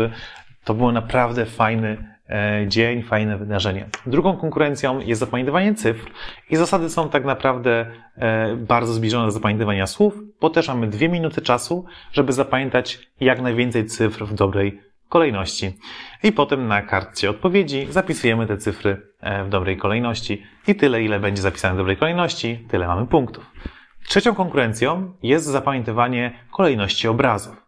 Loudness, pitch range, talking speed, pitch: -20 LUFS, 105-140 Hz, 140 wpm, 115 Hz